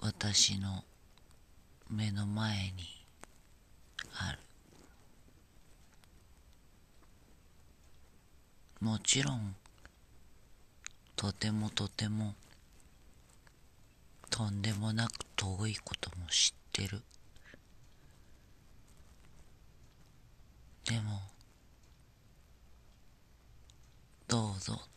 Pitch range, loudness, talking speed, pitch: 80-110 Hz, -35 LUFS, 90 characters per minute, 100 Hz